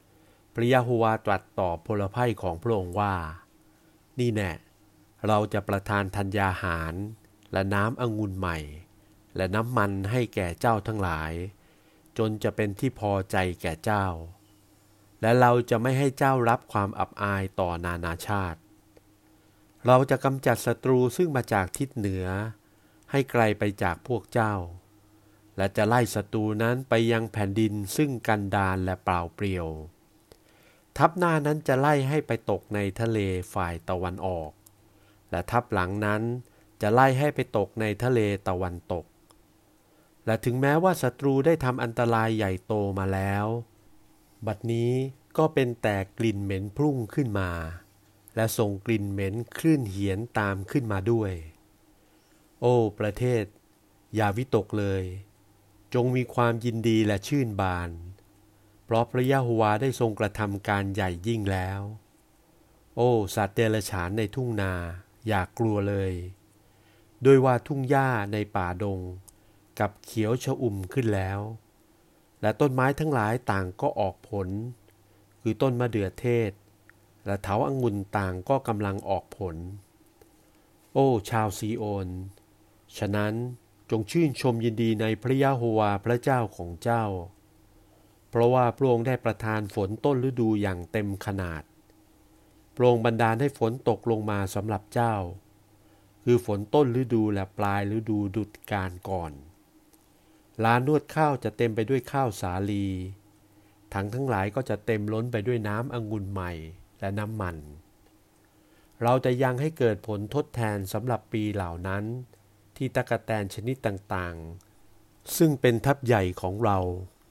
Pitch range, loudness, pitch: 100-120 Hz, -27 LUFS, 105 Hz